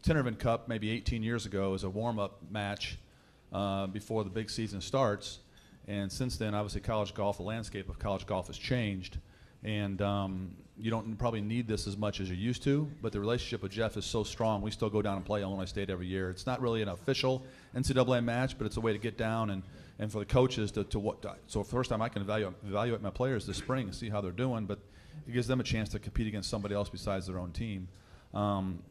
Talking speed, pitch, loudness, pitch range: 240 wpm, 105 Hz, -34 LUFS, 100-115 Hz